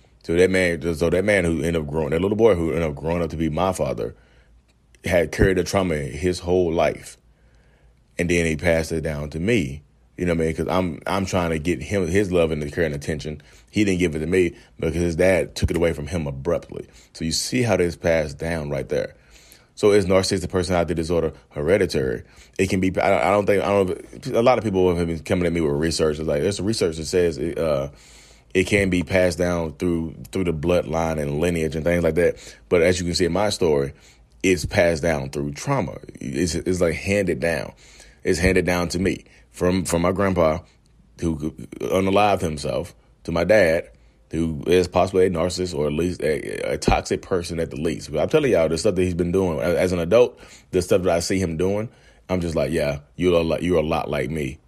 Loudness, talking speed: -22 LUFS, 225 wpm